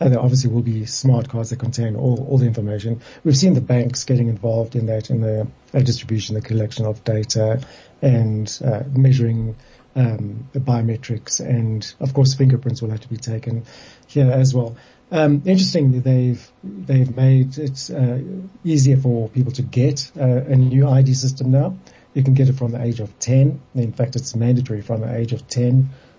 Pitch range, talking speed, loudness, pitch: 115-135 Hz, 190 wpm, -19 LUFS, 125 Hz